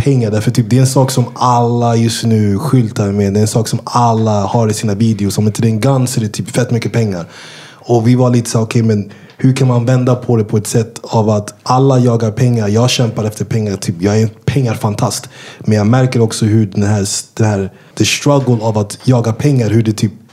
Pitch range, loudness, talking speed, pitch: 110-125 Hz, -13 LUFS, 255 wpm, 115 Hz